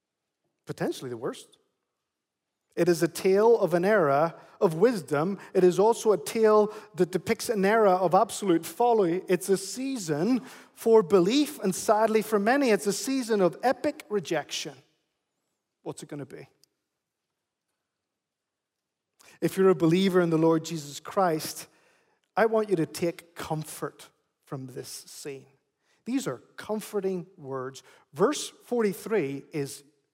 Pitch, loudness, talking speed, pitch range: 190 Hz, -26 LUFS, 135 wpm, 165-220 Hz